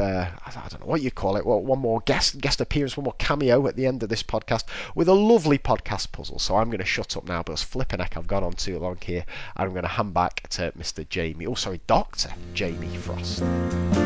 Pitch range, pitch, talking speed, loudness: 85-120 Hz, 100 Hz, 250 wpm, -25 LUFS